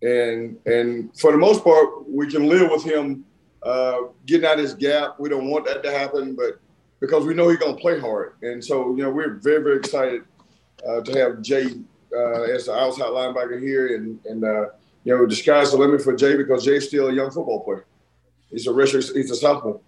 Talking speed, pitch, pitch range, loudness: 225 wpm, 135 Hz, 120-145 Hz, -20 LUFS